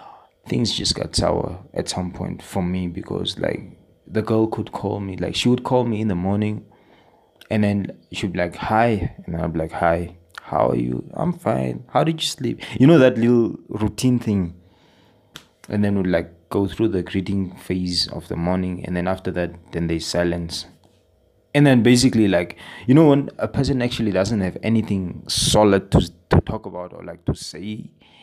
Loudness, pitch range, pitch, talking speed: -21 LUFS, 90-110 Hz, 95 Hz, 195 wpm